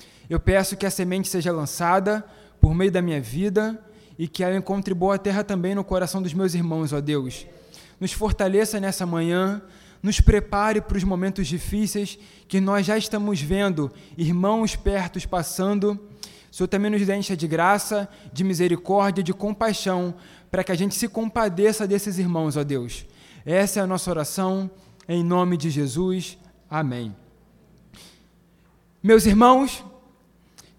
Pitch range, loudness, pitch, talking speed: 175-205 Hz, -23 LUFS, 190 Hz, 150 wpm